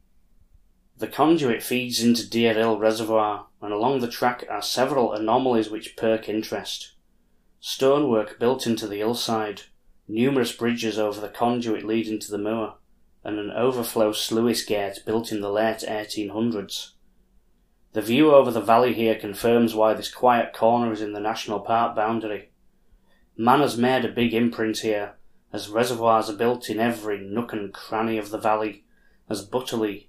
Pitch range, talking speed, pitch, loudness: 105-115 Hz, 160 wpm, 110 Hz, -23 LUFS